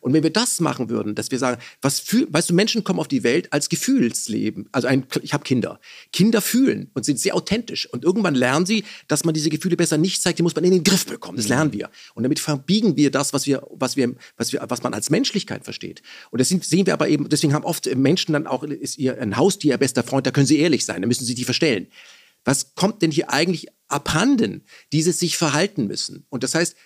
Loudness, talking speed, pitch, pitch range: -20 LUFS, 245 wpm, 155 Hz, 135-185 Hz